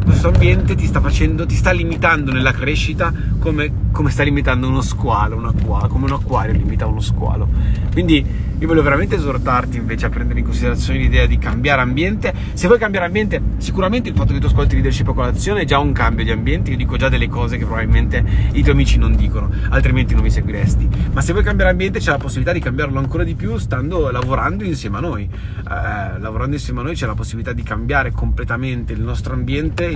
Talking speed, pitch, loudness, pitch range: 210 wpm, 110 Hz, -17 LUFS, 100-125 Hz